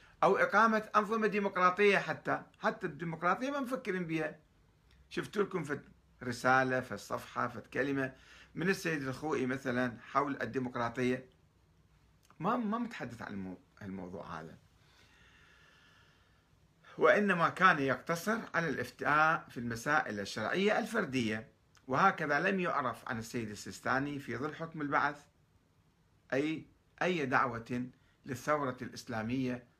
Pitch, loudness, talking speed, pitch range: 135 Hz, -33 LUFS, 110 wpm, 125-180 Hz